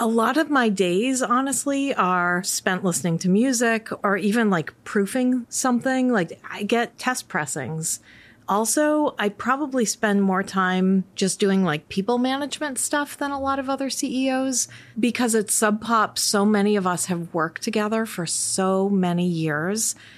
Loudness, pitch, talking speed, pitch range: -22 LUFS, 215 Hz, 160 wpm, 185-255 Hz